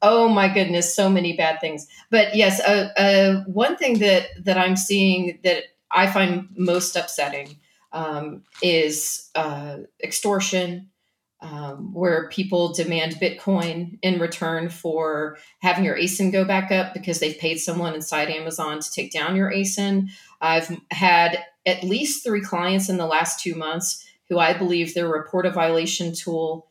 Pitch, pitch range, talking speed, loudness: 175 Hz, 160-195 Hz, 155 wpm, -21 LUFS